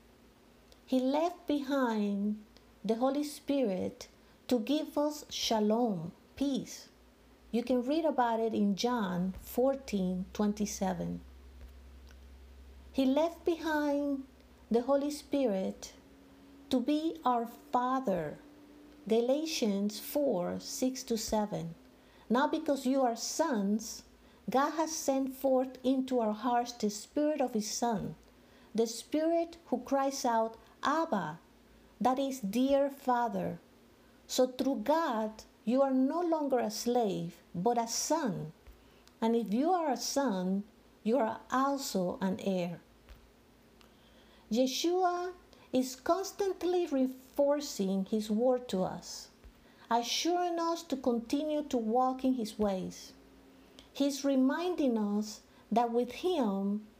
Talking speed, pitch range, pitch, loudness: 115 wpm, 215-280 Hz, 250 Hz, -32 LUFS